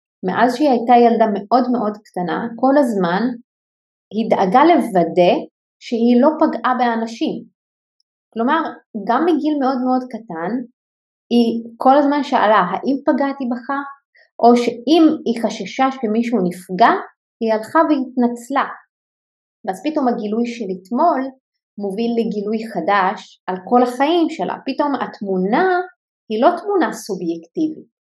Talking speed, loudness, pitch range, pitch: 120 wpm, -17 LUFS, 220-280 Hz, 240 Hz